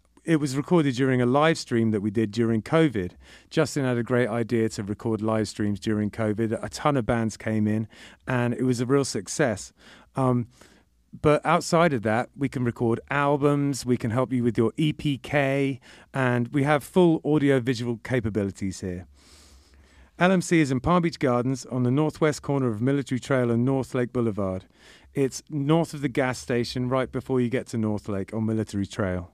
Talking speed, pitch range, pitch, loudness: 190 wpm, 110-140 Hz, 125 Hz, -25 LUFS